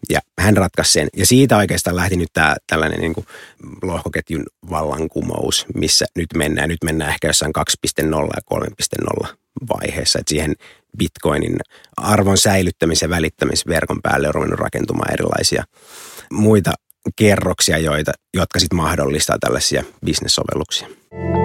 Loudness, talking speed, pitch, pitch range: -17 LUFS, 130 wpm, 85 Hz, 80-95 Hz